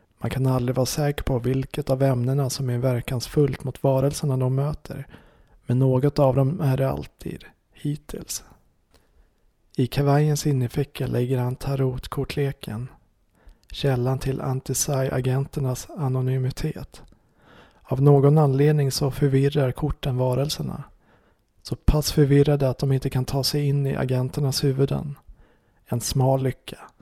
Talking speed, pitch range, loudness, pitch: 130 wpm, 130-140 Hz, -23 LUFS, 135 Hz